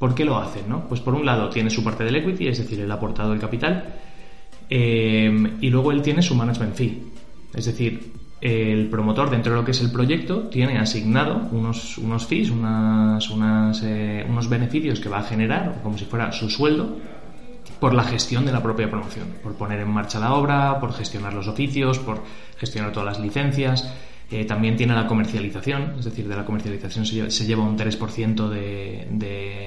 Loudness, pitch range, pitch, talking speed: -22 LUFS, 110-125 Hz, 115 Hz, 200 wpm